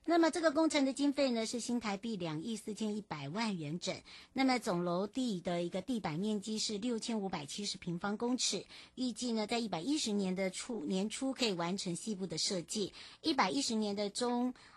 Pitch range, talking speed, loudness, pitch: 190-245 Hz, 305 characters per minute, -36 LUFS, 215 Hz